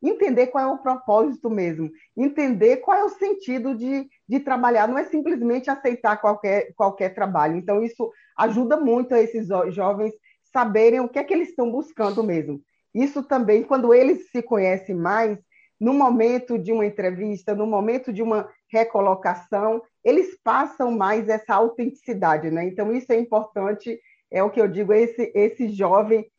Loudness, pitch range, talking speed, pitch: -22 LUFS, 210-255 Hz, 165 wpm, 225 Hz